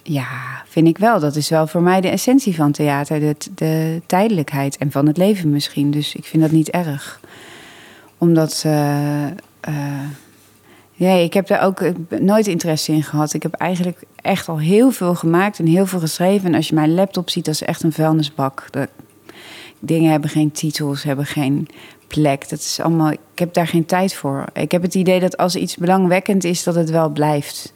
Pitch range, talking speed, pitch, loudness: 150-180 Hz, 200 wpm, 160 Hz, -17 LUFS